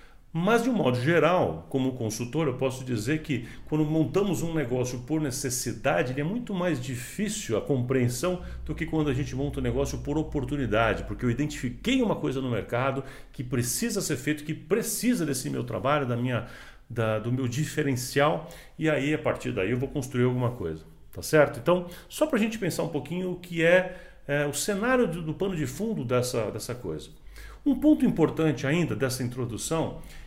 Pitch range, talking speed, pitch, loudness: 125-170 Hz, 190 wpm, 145 Hz, -27 LUFS